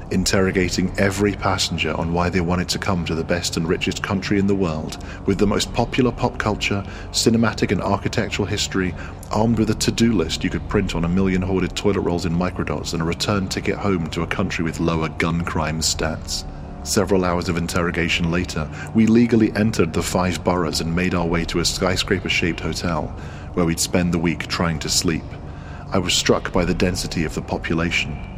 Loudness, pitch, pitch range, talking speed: -21 LUFS, 90 Hz, 85-100 Hz, 200 wpm